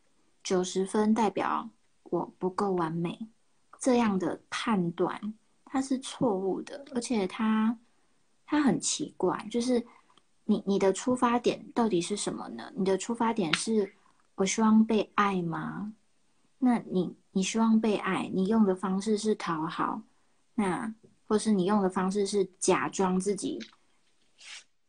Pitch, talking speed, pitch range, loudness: 210 Hz, 195 characters per minute, 190-230 Hz, -29 LUFS